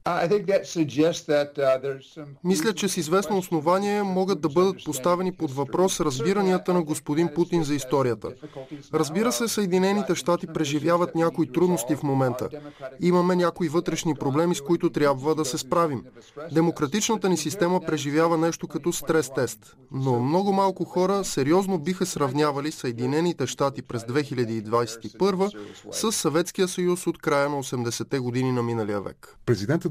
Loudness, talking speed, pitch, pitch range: -25 LUFS, 130 wpm, 160 Hz, 140-180 Hz